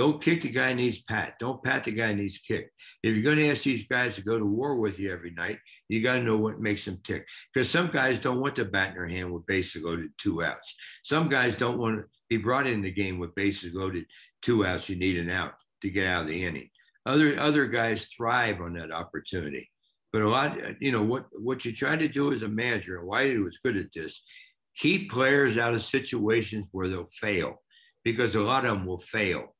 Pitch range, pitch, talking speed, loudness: 95-130 Hz, 110 Hz, 240 wpm, -28 LUFS